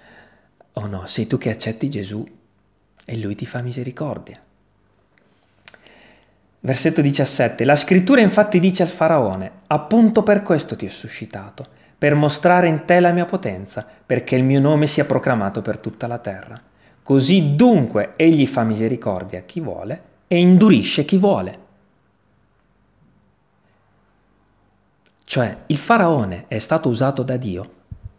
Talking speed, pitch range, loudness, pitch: 135 wpm, 110-160 Hz, -18 LUFS, 130 Hz